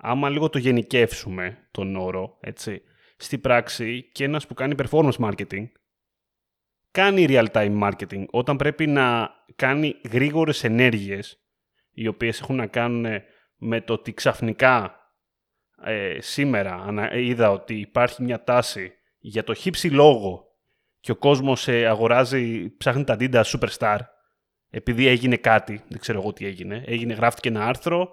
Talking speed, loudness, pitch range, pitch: 140 wpm, -22 LUFS, 110-130 Hz, 120 Hz